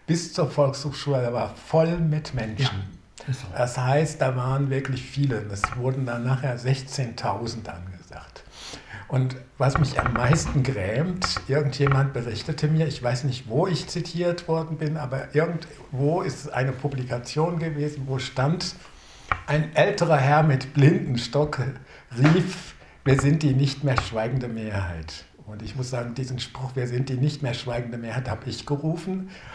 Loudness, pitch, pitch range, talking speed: -25 LUFS, 135 Hz, 125-150 Hz, 150 wpm